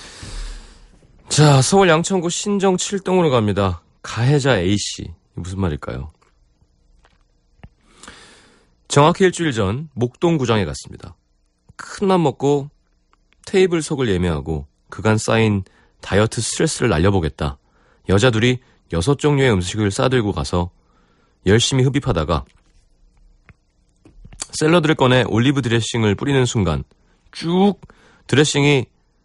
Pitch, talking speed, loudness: 110 Hz, 245 characters per minute, -18 LUFS